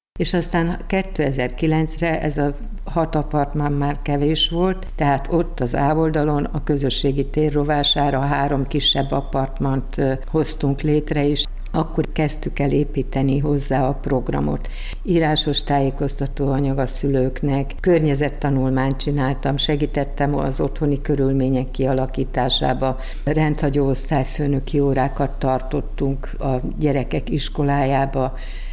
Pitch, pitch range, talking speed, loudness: 140 Hz, 135-150 Hz, 105 wpm, -21 LUFS